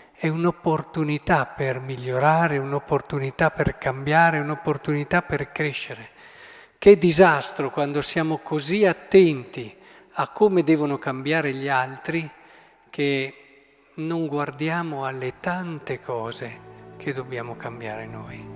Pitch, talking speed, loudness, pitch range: 150 Hz, 105 wpm, -23 LUFS, 135-165 Hz